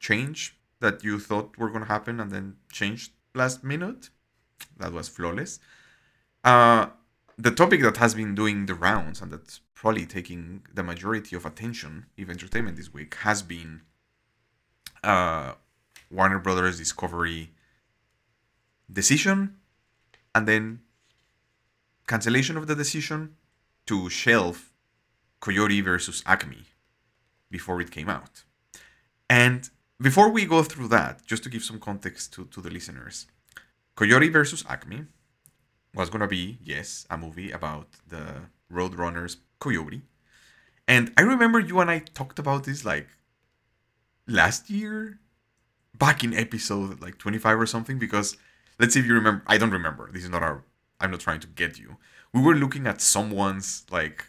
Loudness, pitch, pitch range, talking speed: -24 LUFS, 110 Hz, 95-125 Hz, 145 wpm